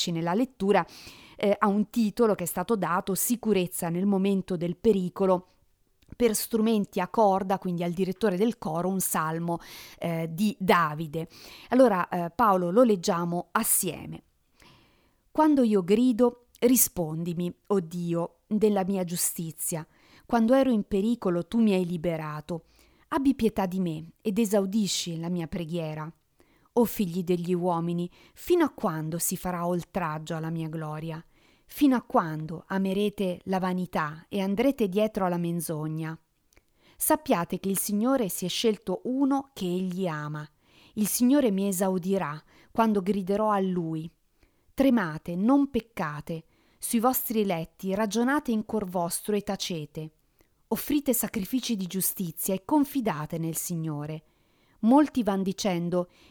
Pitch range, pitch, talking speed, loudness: 170-220 Hz, 190 Hz, 135 wpm, -27 LUFS